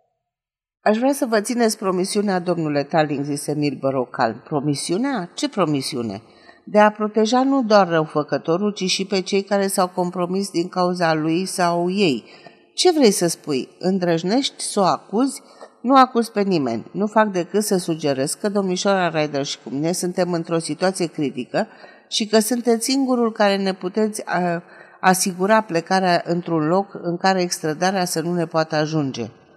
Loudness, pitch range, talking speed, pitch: -20 LUFS, 160-205 Hz, 160 wpm, 180 Hz